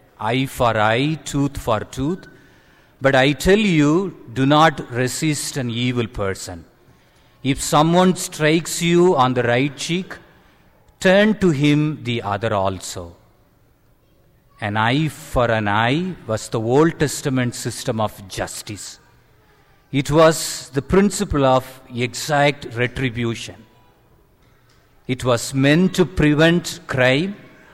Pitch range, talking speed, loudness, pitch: 120-155 Hz, 120 wpm, -19 LUFS, 135 Hz